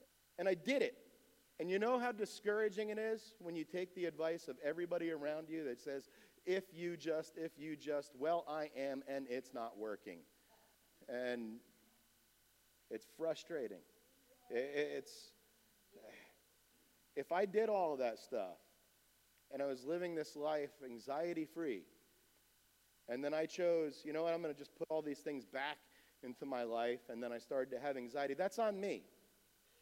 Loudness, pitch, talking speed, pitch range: -42 LUFS, 160 Hz, 165 wpm, 140-190 Hz